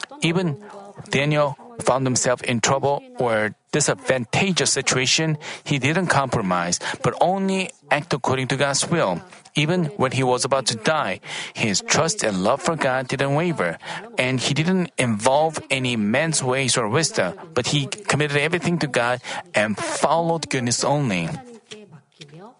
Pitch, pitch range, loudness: 145 Hz, 130-170 Hz, -21 LUFS